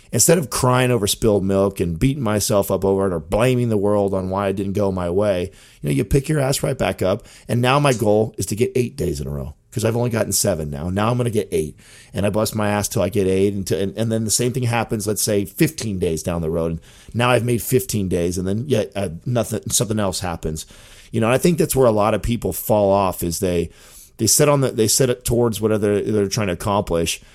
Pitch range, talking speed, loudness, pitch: 95-120 Hz, 270 wpm, -19 LUFS, 105 Hz